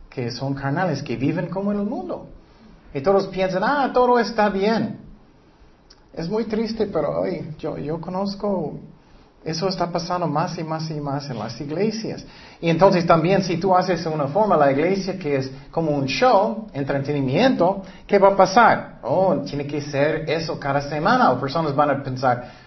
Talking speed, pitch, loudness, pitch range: 175 wpm, 165 Hz, -21 LUFS, 145-195 Hz